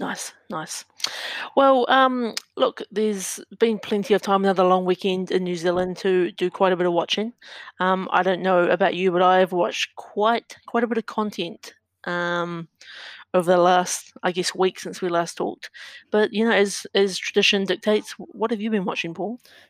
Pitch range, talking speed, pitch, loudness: 180-215 Hz, 190 wpm, 190 Hz, -22 LUFS